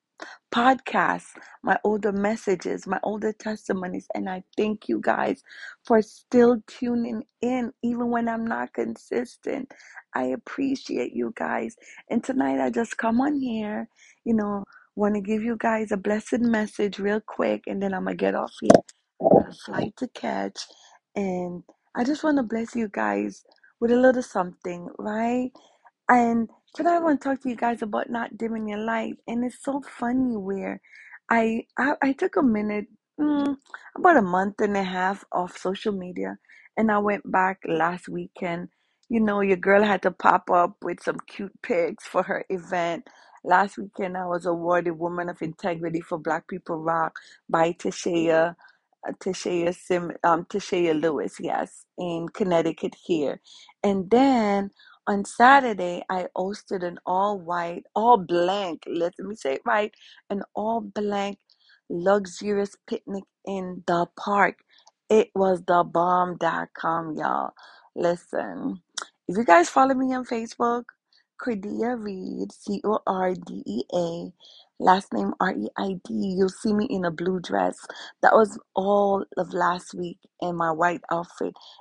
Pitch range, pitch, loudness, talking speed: 175-230 Hz, 200 Hz, -25 LUFS, 150 wpm